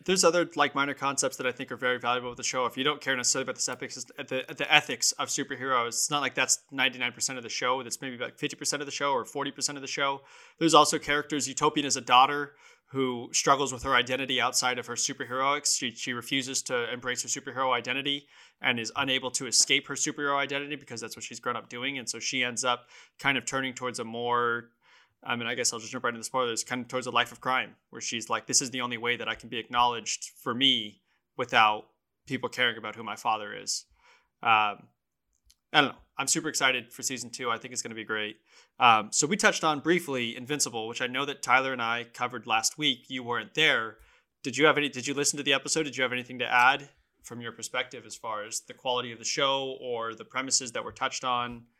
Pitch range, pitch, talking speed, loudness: 120-140 Hz, 130 Hz, 240 wpm, -28 LUFS